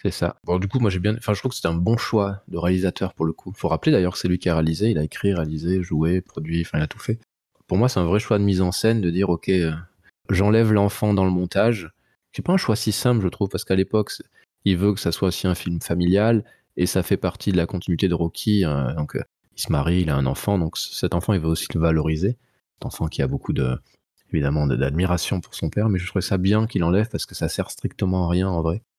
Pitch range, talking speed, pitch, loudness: 85-105 Hz, 285 wpm, 95 Hz, -22 LUFS